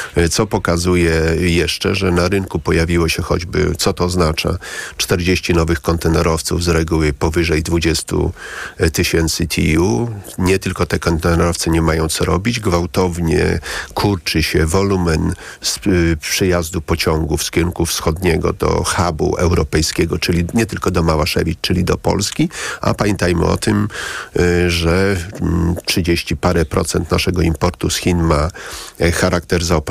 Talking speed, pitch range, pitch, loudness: 130 wpm, 85-90 Hz, 85 Hz, -16 LUFS